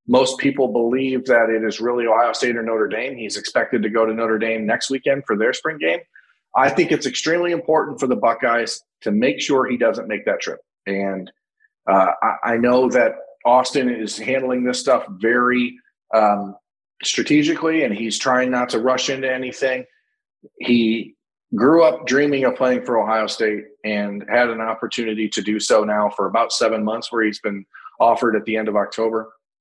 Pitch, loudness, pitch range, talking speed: 120 Hz, -19 LUFS, 110-135 Hz, 190 wpm